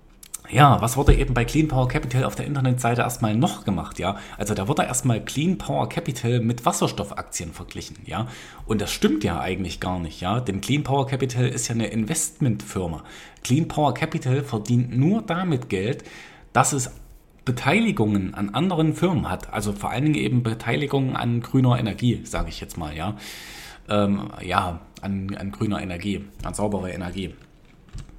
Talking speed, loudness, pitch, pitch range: 170 wpm, -24 LUFS, 115 Hz, 100-140 Hz